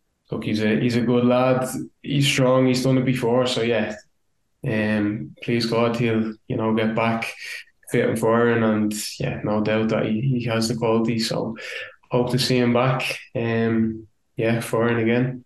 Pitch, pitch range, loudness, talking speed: 115 Hz, 110-125 Hz, -22 LUFS, 180 wpm